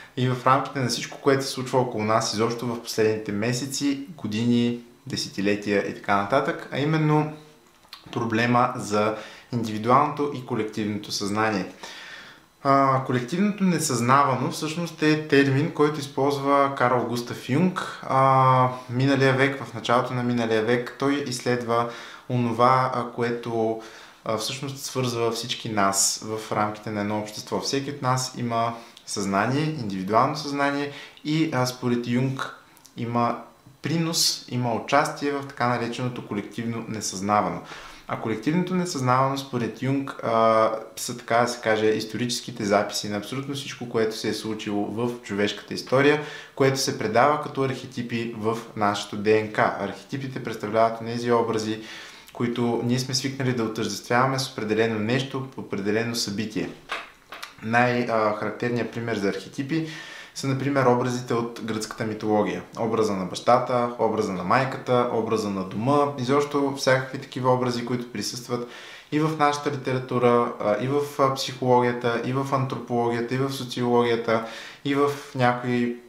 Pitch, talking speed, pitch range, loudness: 120 Hz, 130 wpm, 110-135 Hz, -24 LUFS